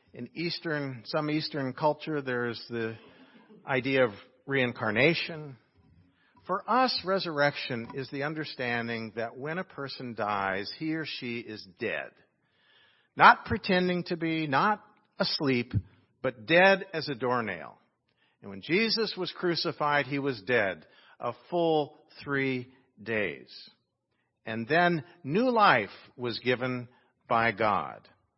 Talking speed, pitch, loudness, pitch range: 120 wpm, 140 Hz, -29 LUFS, 120-165 Hz